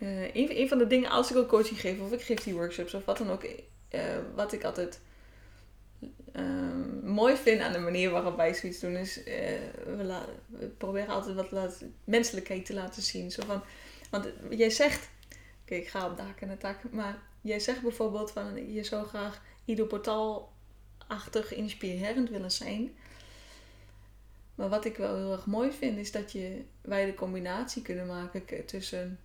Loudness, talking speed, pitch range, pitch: -32 LUFS, 185 wpm, 180-230 Hz, 200 Hz